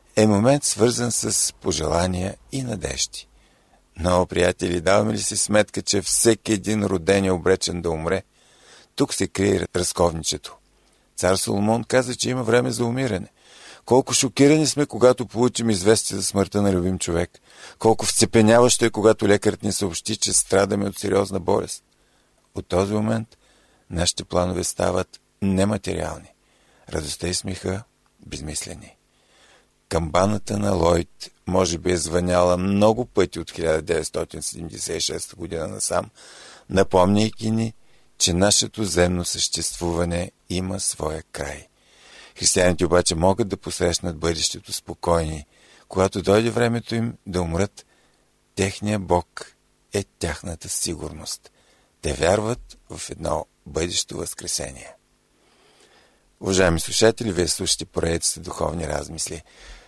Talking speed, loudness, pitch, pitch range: 120 wpm, -22 LUFS, 95 Hz, 90-110 Hz